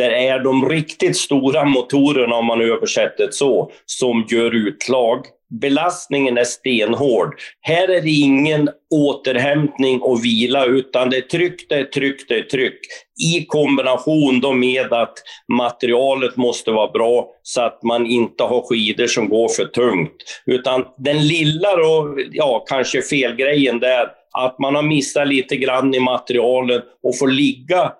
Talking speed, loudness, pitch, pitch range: 155 wpm, -17 LUFS, 135 Hz, 120-150 Hz